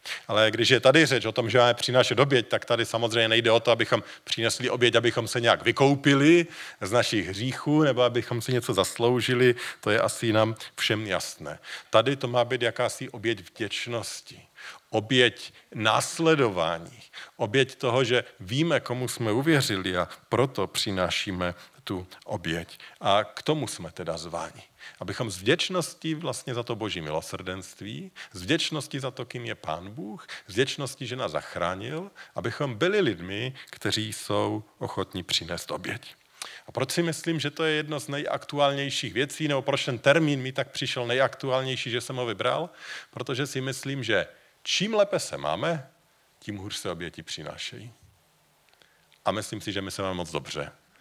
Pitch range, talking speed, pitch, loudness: 110-140 Hz, 165 wpm, 125 Hz, -26 LUFS